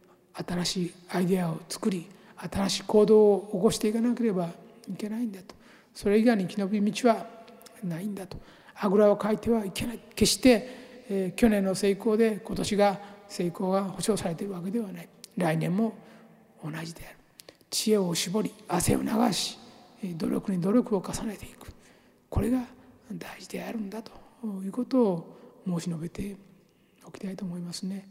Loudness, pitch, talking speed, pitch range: -27 LUFS, 205 Hz, 320 characters per minute, 185-225 Hz